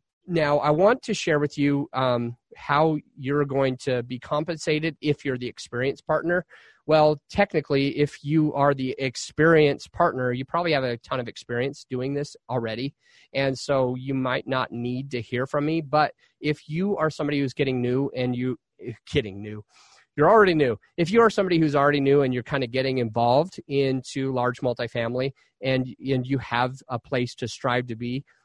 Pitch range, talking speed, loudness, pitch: 125-150 Hz, 185 wpm, -24 LUFS, 135 Hz